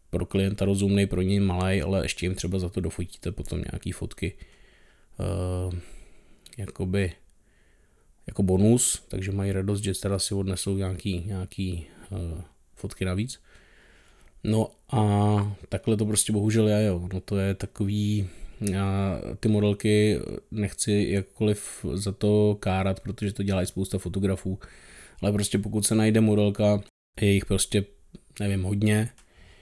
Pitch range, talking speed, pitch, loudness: 95-105 Hz, 140 wpm, 100 Hz, -26 LUFS